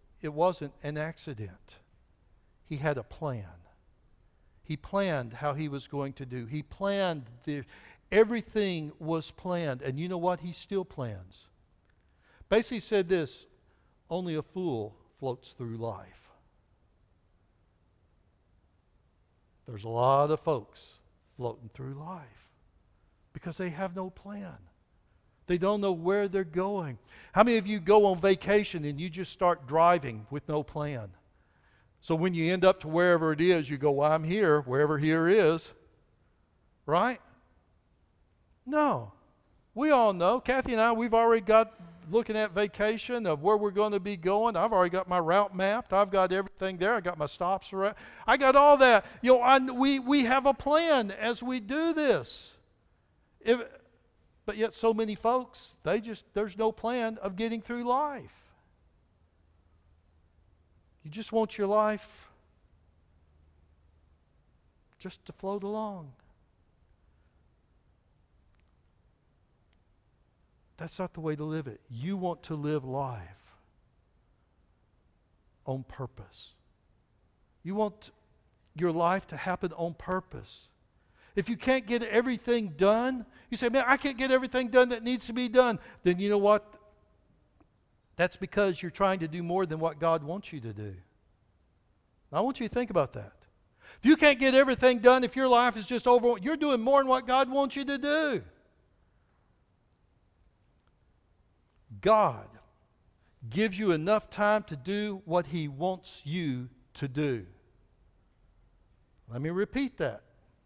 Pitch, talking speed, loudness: 170 Hz, 145 wpm, -28 LUFS